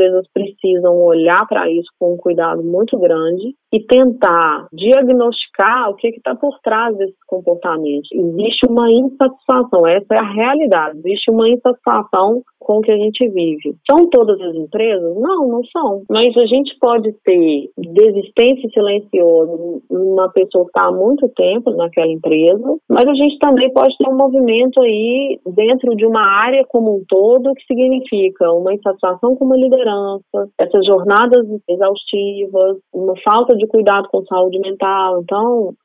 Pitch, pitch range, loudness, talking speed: 210 Hz, 185-250 Hz, -13 LUFS, 150 wpm